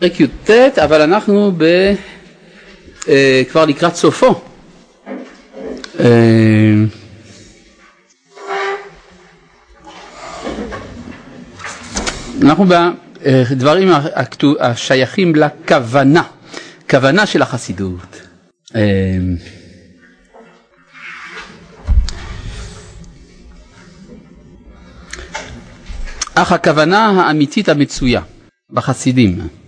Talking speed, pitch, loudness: 40 wpm, 130 Hz, -12 LUFS